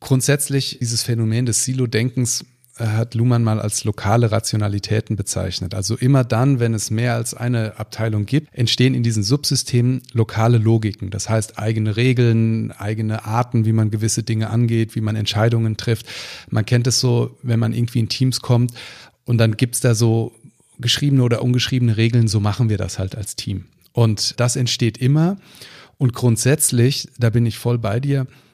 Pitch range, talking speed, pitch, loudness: 110-125 Hz, 175 wpm, 115 Hz, -19 LUFS